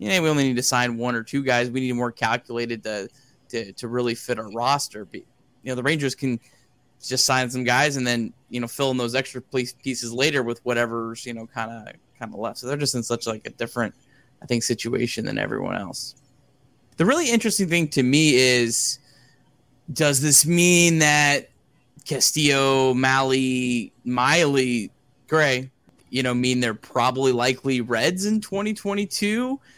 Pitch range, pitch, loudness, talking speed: 120-140 Hz, 130 Hz, -22 LUFS, 185 wpm